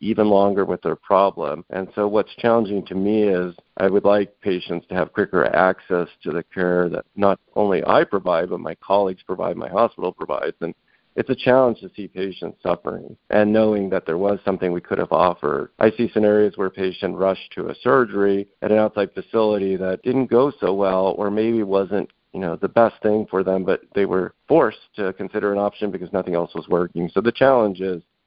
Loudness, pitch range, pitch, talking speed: -21 LUFS, 95-105 Hz, 100 Hz, 210 wpm